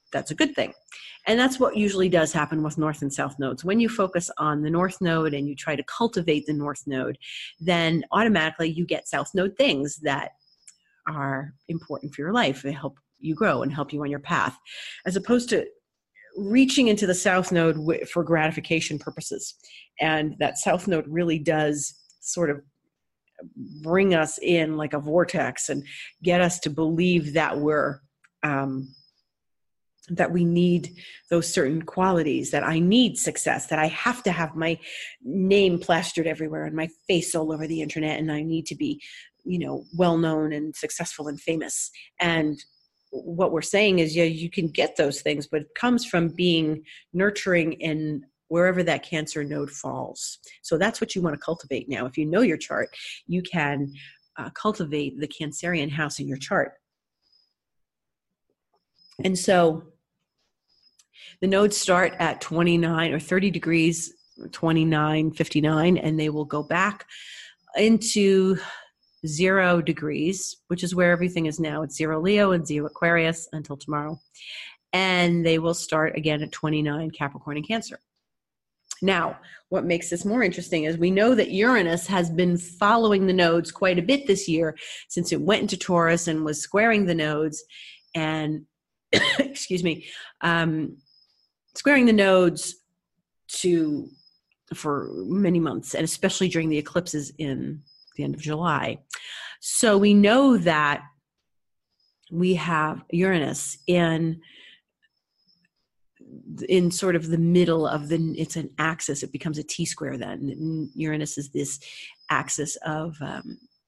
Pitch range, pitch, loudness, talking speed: 155-180 Hz, 165 Hz, -24 LUFS, 155 wpm